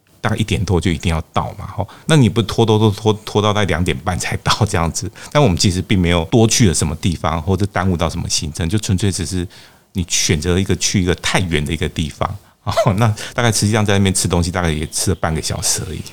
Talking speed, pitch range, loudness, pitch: 370 characters per minute, 85-110 Hz, -17 LUFS, 95 Hz